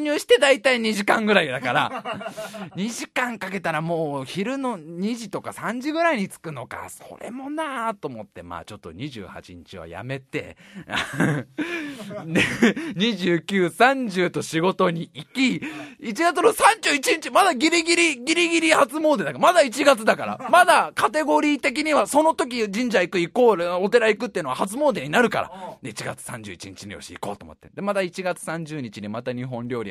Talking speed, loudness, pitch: 295 characters per minute, -21 LUFS, 220 Hz